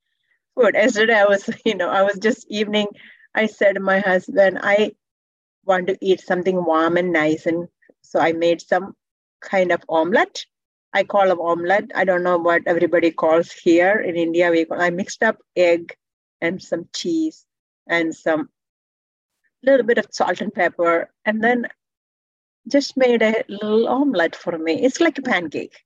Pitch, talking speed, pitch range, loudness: 190 Hz, 165 wpm, 170-220 Hz, -19 LUFS